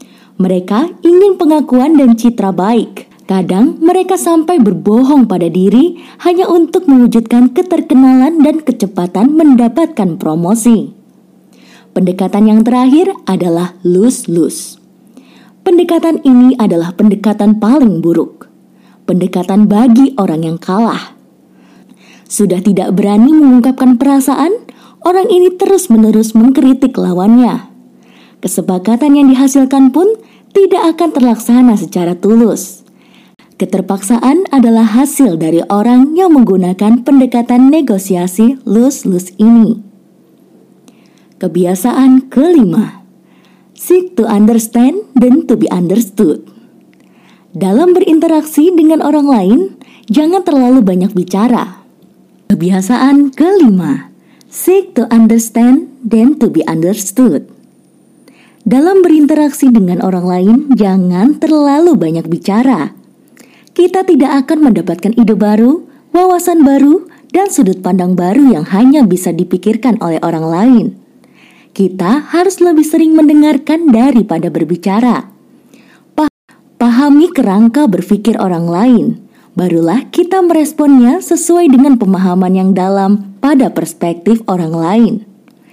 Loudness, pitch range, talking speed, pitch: -9 LUFS, 200-290 Hz, 100 wpm, 240 Hz